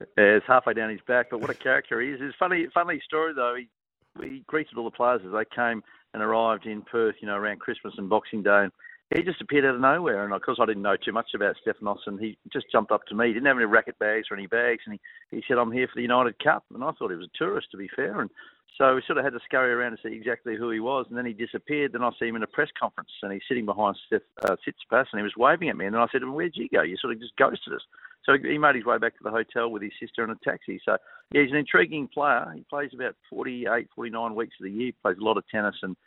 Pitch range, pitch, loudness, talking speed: 110-135 Hz, 120 Hz, -26 LUFS, 300 wpm